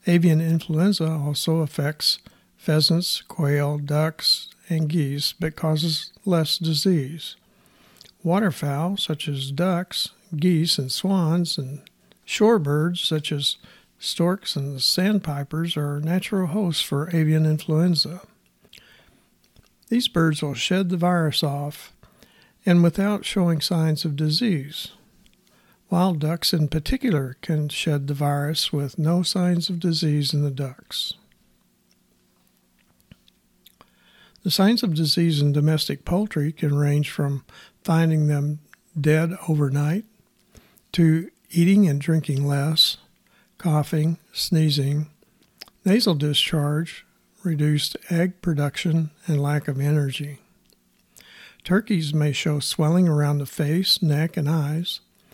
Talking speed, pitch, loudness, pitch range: 110 wpm, 160 Hz, -22 LUFS, 150-175 Hz